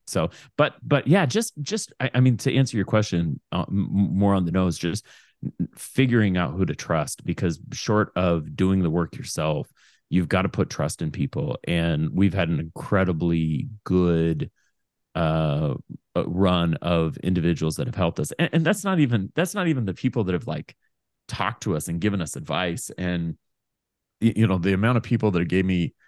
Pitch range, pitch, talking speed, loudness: 85-120 Hz, 95 Hz, 190 wpm, -24 LUFS